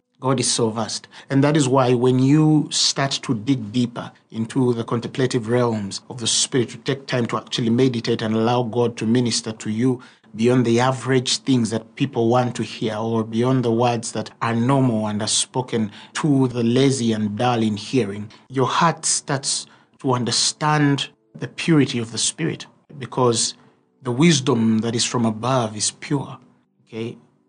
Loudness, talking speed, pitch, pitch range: -20 LUFS, 175 wpm, 120 Hz, 110-130 Hz